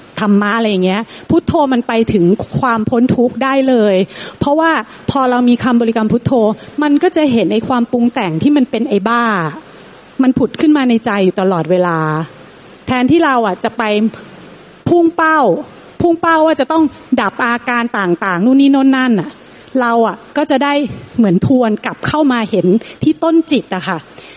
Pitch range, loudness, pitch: 210-275 Hz, -13 LUFS, 240 Hz